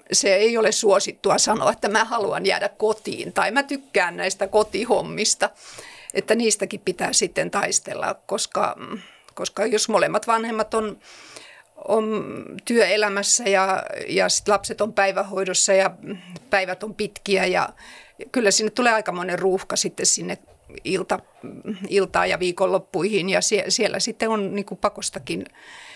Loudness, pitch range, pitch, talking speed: -21 LUFS, 195-215 Hz, 200 Hz, 135 wpm